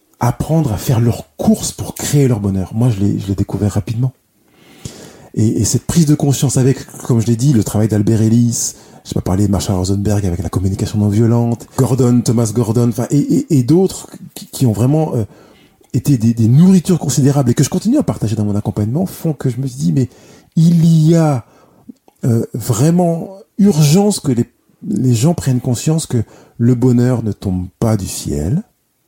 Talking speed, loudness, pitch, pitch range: 195 wpm, -15 LUFS, 125 Hz, 110-150 Hz